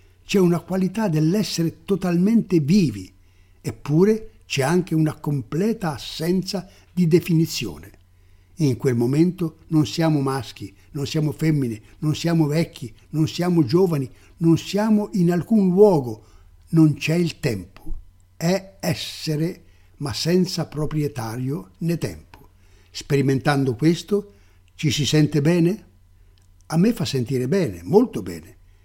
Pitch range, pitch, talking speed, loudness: 105-170 Hz, 150 Hz, 120 wpm, -21 LUFS